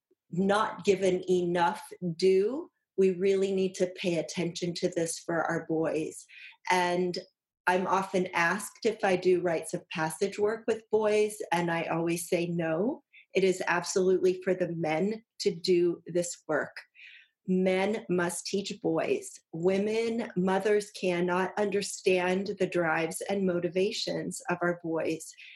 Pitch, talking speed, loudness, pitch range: 185 Hz, 135 wpm, -29 LUFS, 175-200 Hz